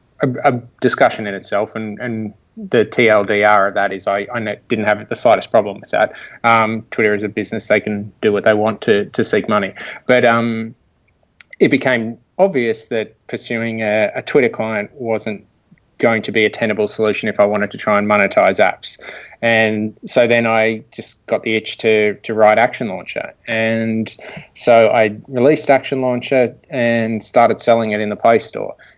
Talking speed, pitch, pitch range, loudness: 180 wpm, 110 Hz, 105-120 Hz, -16 LUFS